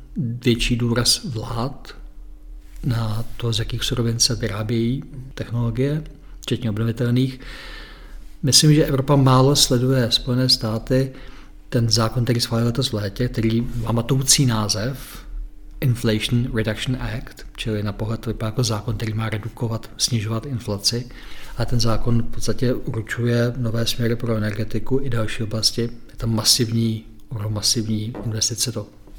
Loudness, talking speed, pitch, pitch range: -21 LUFS, 135 wpm, 115 Hz, 110-125 Hz